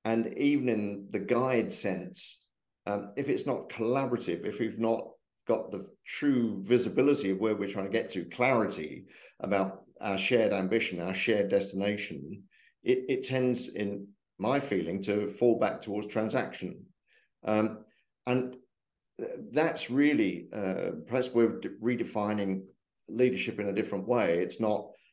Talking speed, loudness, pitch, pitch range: 145 wpm, -31 LUFS, 115 Hz, 100-125 Hz